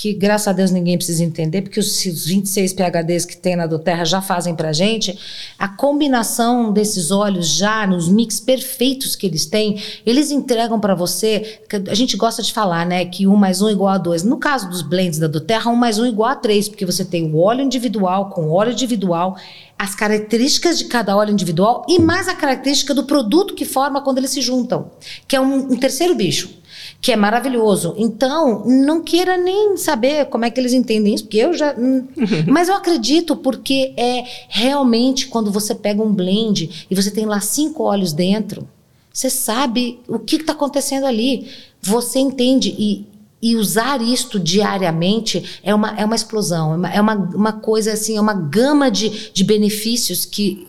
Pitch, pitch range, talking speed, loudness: 215 Hz, 195-260 Hz, 195 wpm, -17 LUFS